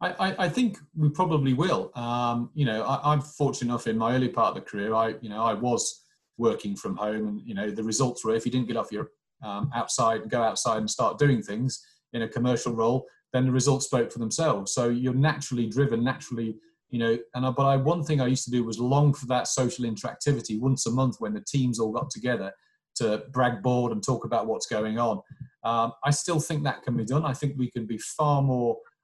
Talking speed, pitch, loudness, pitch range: 240 wpm, 125 Hz, -27 LUFS, 115-140 Hz